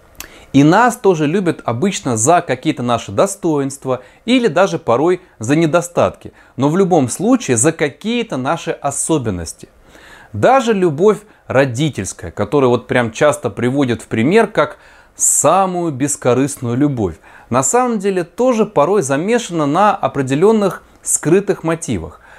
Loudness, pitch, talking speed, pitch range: -15 LUFS, 155 Hz, 125 wpm, 130-195 Hz